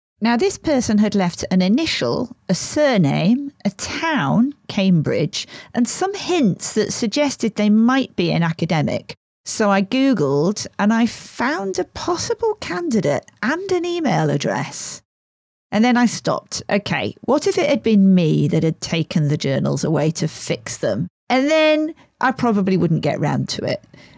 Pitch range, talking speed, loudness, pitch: 175-270 Hz, 160 wpm, -19 LUFS, 215 Hz